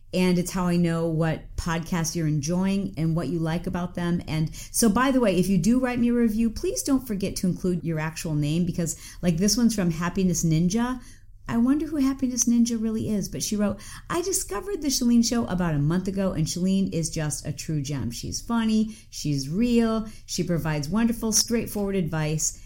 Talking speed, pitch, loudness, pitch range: 205 wpm, 180 Hz, -25 LUFS, 160-230 Hz